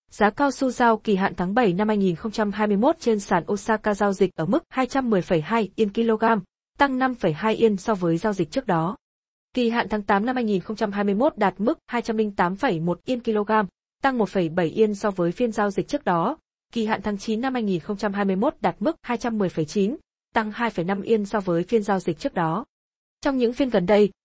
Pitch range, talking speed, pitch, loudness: 195-235 Hz, 180 wpm, 215 Hz, -23 LUFS